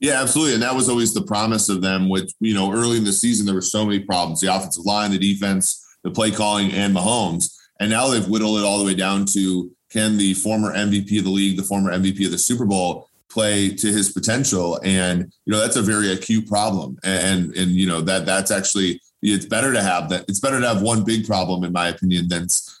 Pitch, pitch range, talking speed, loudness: 100 Hz, 95-110 Hz, 240 wpm, -19 LUFS